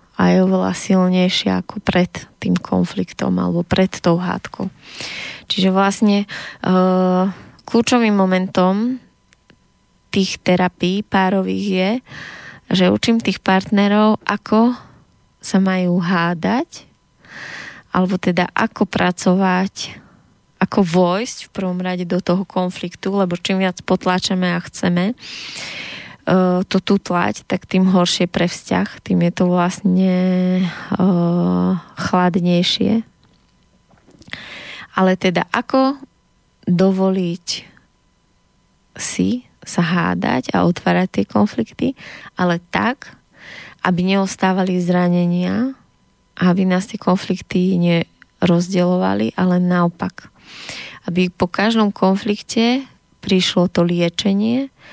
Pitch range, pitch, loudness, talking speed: 180-195 Hz, 185 Hz, -18 LUFS, 100 wpm